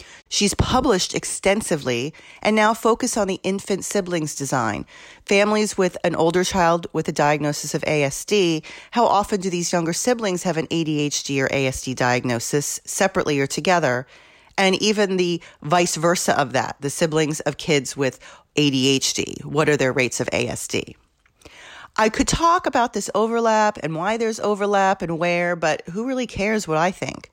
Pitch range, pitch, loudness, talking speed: 145-205 Hz, 175 Hz, -21 LUFS, 165 wpm